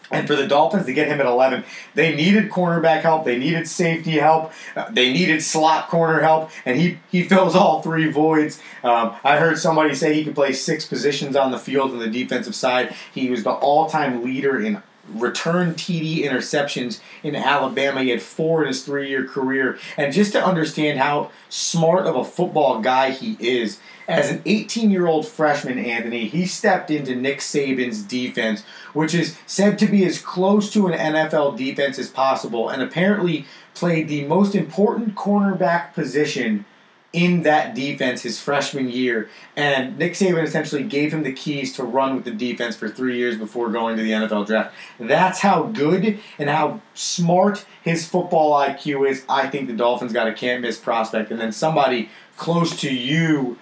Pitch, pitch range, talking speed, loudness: 155 Hz, 130-175 Hz, 180 wpm, -20 LUFS